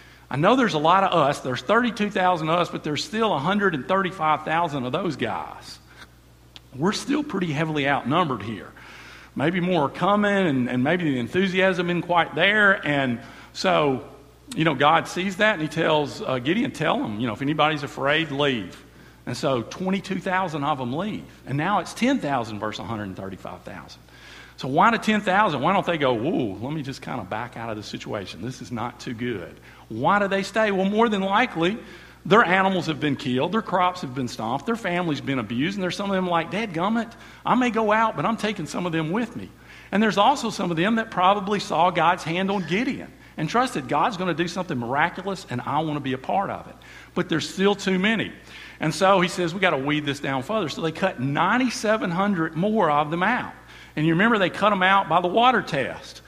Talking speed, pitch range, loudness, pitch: 215 wpm, 140-200 Hz, -23 LUFS, 175 Hz